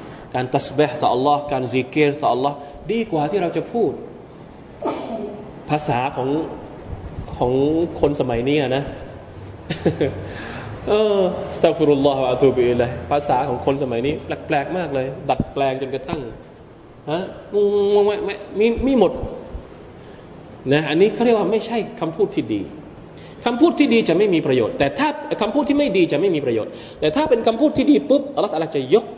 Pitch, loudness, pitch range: 155 Hz, -20 LUFS, 135-215 Hz